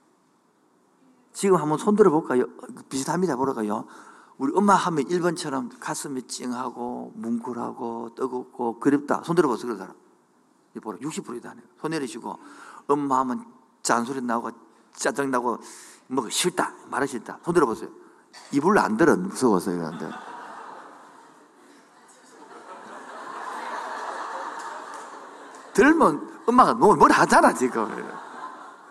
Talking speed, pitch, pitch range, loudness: 235 characters per minute, 130 Hz, 125-155 Hz, -24 LUFS